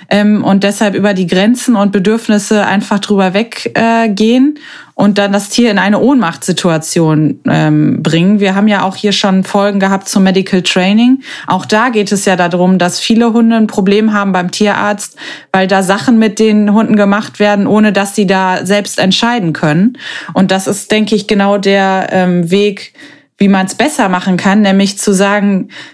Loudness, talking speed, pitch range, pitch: -10 LUFS, 175 wpm, 190-215 Hz, 205 Hz